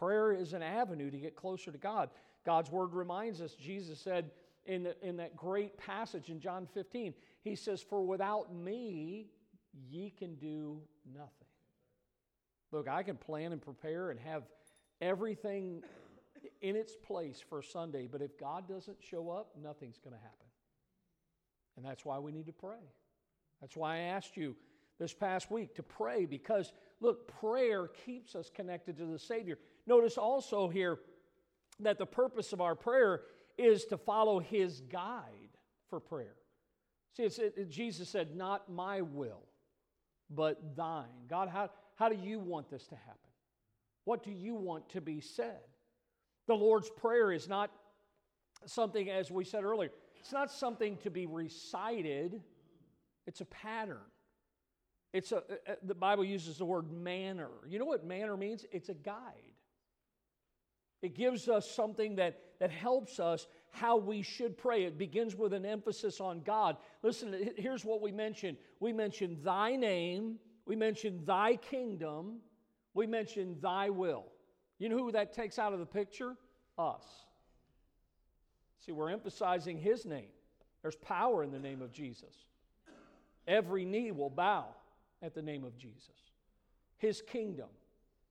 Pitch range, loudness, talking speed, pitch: 165-215 Hz, -38 LUFS, 155 wpm, 190 Hz